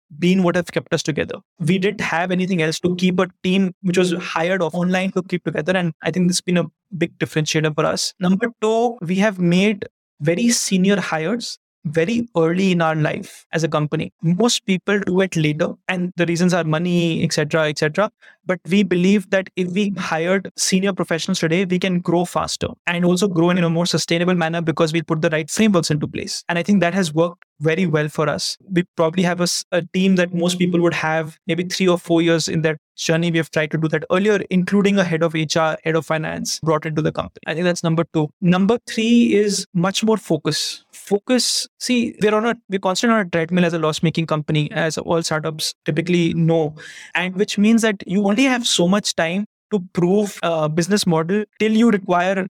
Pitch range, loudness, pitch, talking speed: 165-195 Hz, -19 LUFS, 175 Hz, 220 wpm